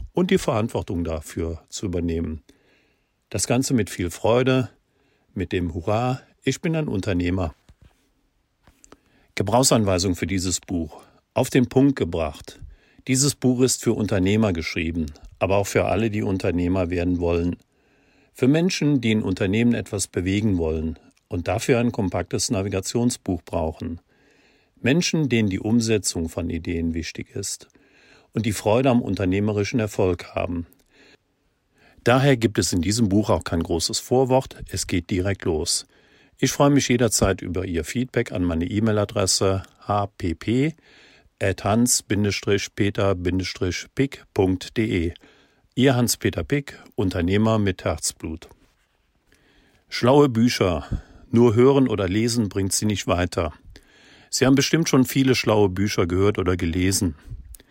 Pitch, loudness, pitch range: 105 Hz, -22 LUFS, 90-120 Hz